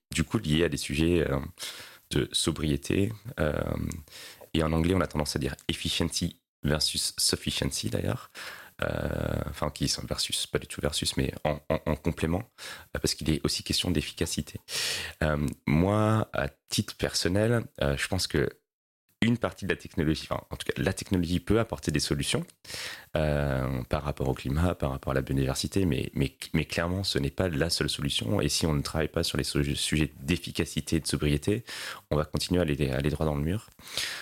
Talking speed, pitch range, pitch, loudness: 180 wpm, 75-85 Hz, 80 Hz, -29 LUFS